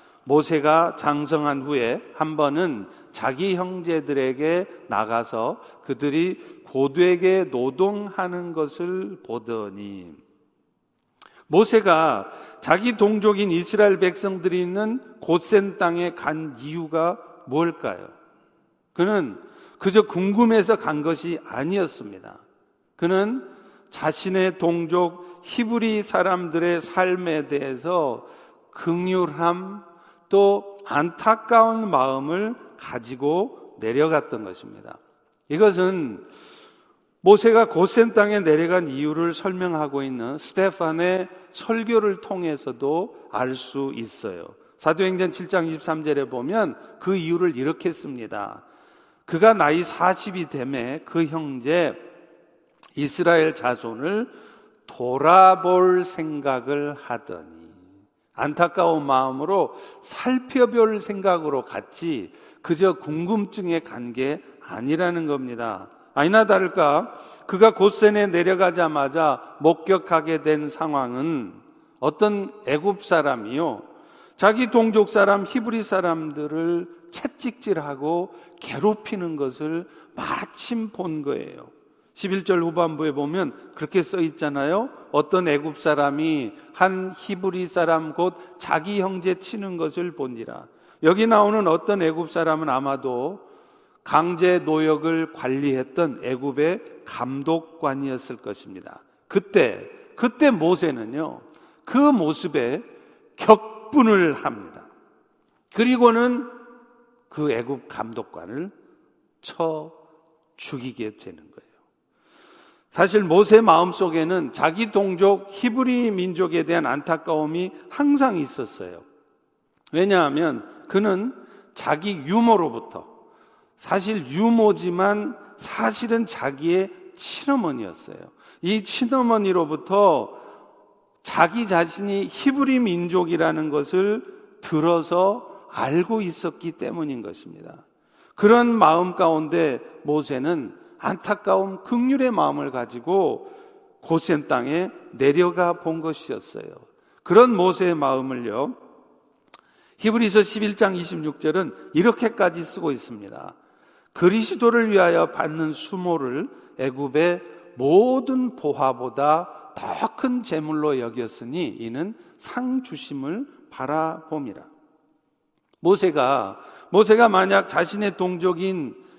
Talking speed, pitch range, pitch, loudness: 225 characters per minute, 155-220 Hz, 180 Hz, -22 LUFS